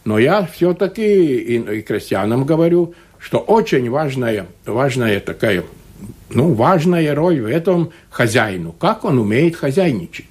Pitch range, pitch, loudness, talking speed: 115-180 Hz, 160 Hz, -16 LUFS, 135 wpm